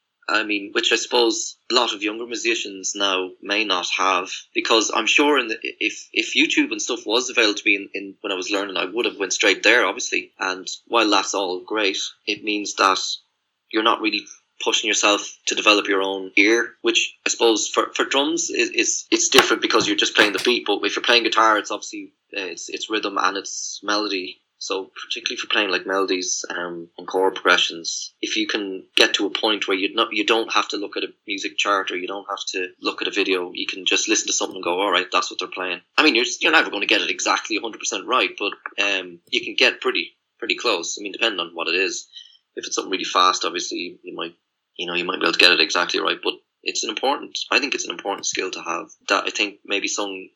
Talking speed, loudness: 245 wpm, -20 LUFS